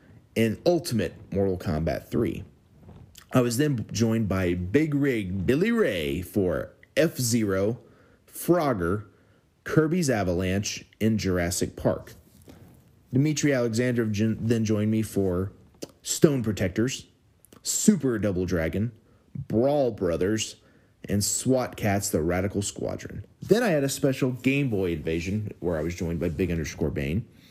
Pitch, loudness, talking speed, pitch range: 110 Hz, -26 LUFS, 125 wpm, 95-125 Hz